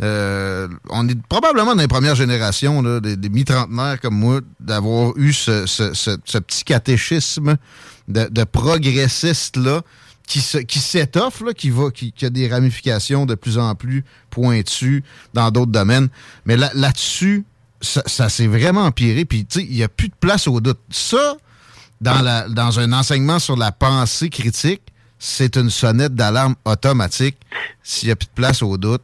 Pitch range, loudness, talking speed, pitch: 115-140 Hz, -17 LUFS, 160 wpm, 125 Hz